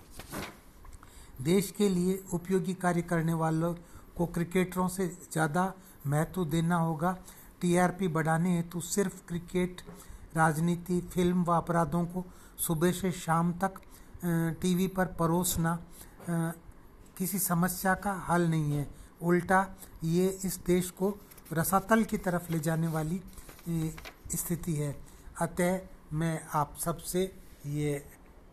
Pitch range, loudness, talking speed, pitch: 165-185 Hz, -31 LUFS, 120 wpm, 175 Hz